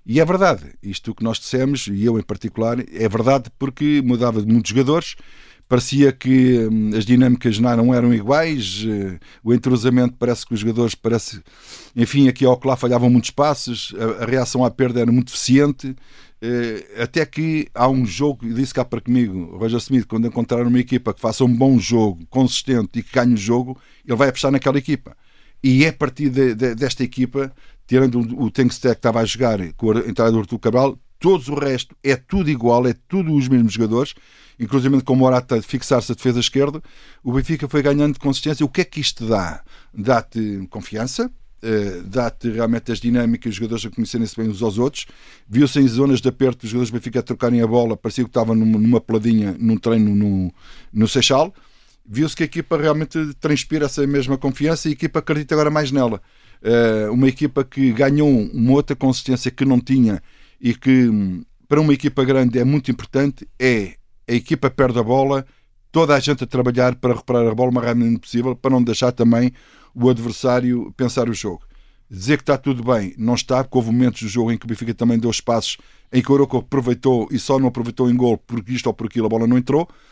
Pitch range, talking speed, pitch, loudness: 115-135 Hz, 200 wpm, 125 Hz, -18 LUFS